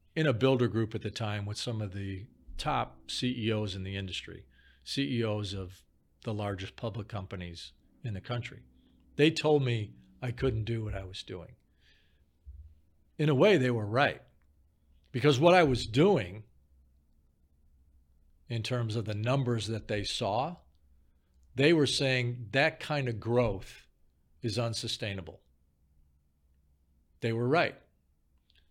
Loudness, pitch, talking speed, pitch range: -30 LUFS, 105 Hz, 140 wpm, 75-120 Hz